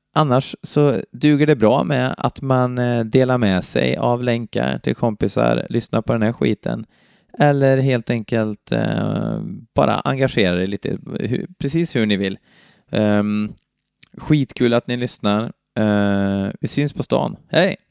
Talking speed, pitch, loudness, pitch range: 135 wpm, 120 Hz, -19 LUFS, 105-135 Hz